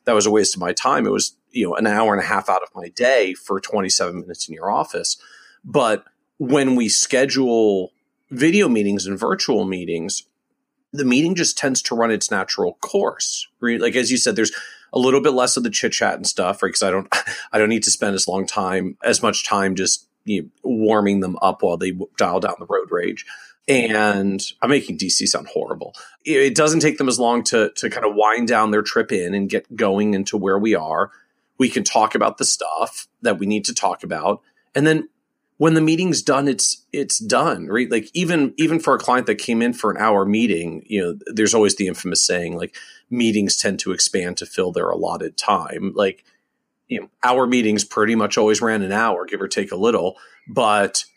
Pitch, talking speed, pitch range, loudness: 115 Hz, 215 wpm, 105-140 Hz, -19 LUFS